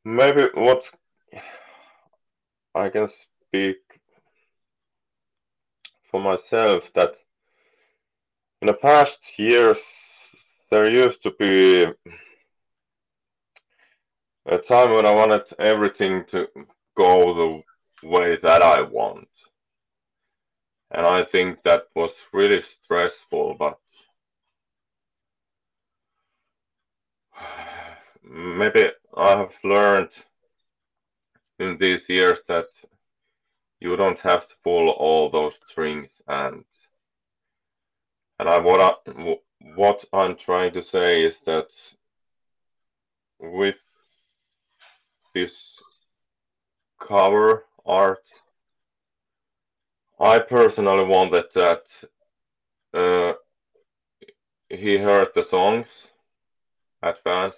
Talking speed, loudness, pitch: 85 wpm, -19 LUFS, 125 Hz